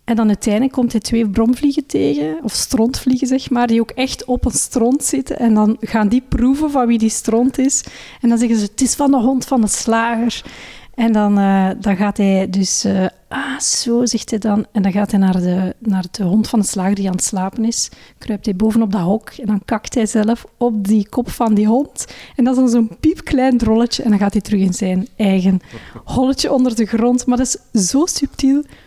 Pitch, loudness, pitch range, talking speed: 225 Hz, -16 LUFS, 205-250 Hz, 230 wpm